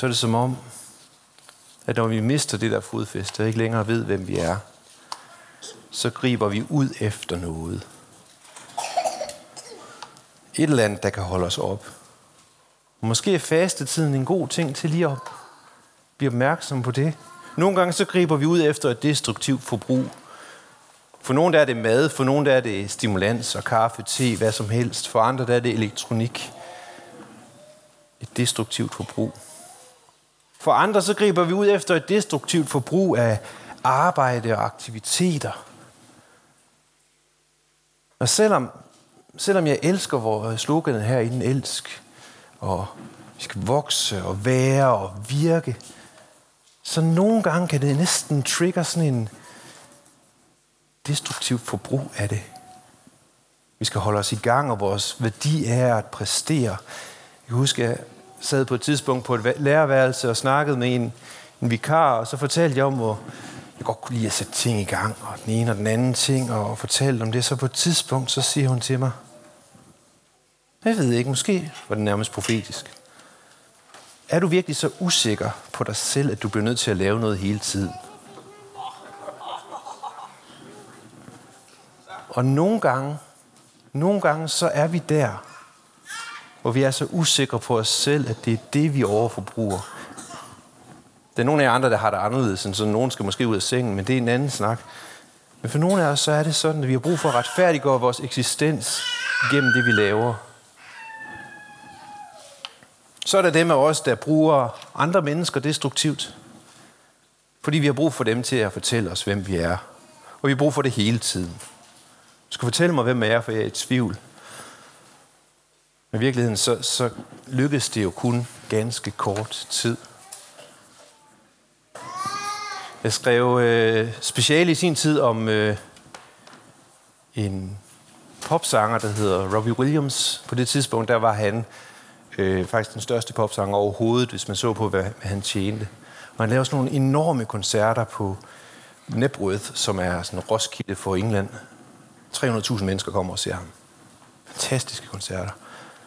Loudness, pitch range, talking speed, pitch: -22 LUFS, 110-150 Hz, 165 wpm, 125 Hz